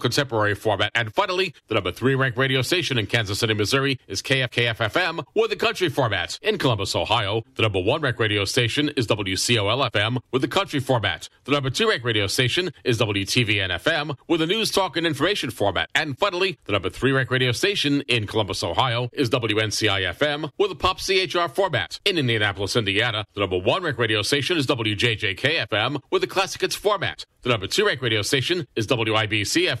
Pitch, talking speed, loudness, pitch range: 125 Hz, 185 wpm, -22 LUFS, 110-145 Hz